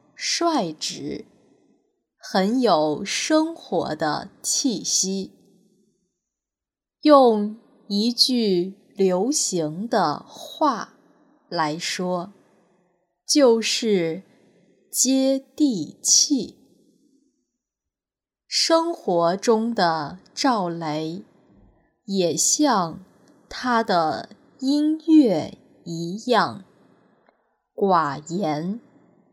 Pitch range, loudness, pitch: 180-270 Hz, -21 LUFS, 205 Hz